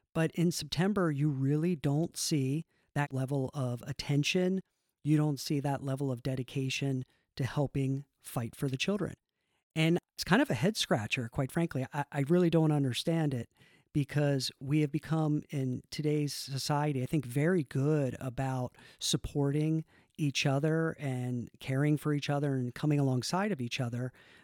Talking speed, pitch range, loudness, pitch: 160 wpm, 135-155 Hz, -32 LUFS, 145 Hz